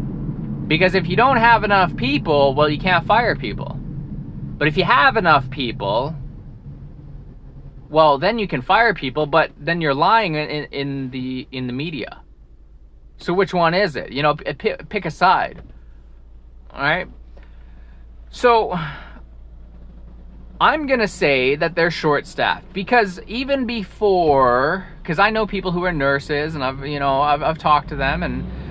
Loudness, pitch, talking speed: -18 LUFS, 145 Hz, 155 wpm